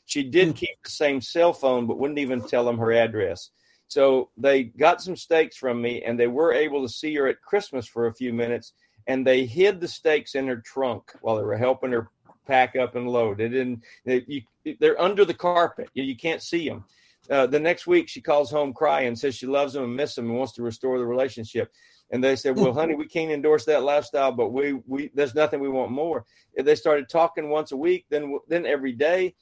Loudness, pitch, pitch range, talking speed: -24 LUFS, 135 Hz, 125-155 Hz, 230 wpm